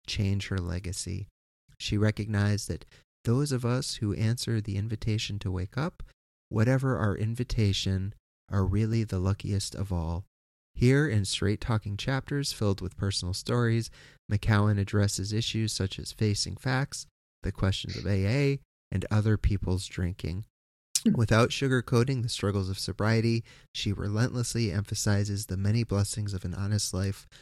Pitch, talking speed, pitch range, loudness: 105 Hz, 140 wpm, 95-115 Hz, -29 LUFS